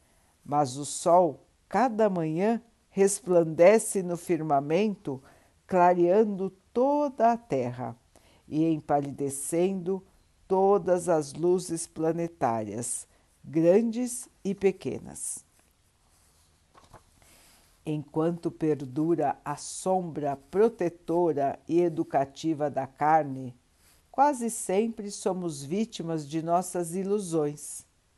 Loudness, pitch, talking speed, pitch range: -27 LUFS, 165 Hz, 80 wpm, 140-190 Hz